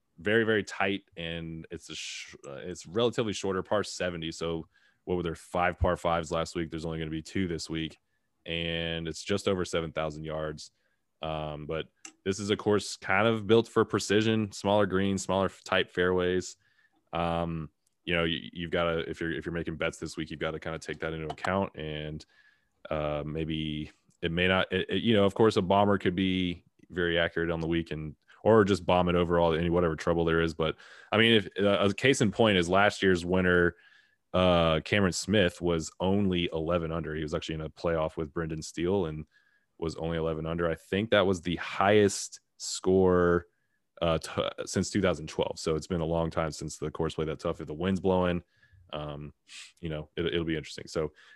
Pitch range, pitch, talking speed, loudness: 80-95 Hz, 85 Hz, 210 wpm, -29 LUFS